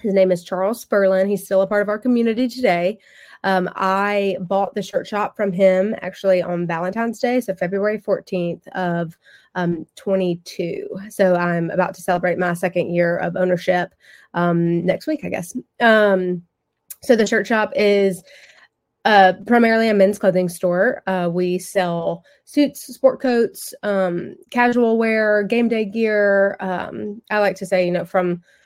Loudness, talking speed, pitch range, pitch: -19 LUFS, 165 wpm, 180-215 Hz, 195 Hz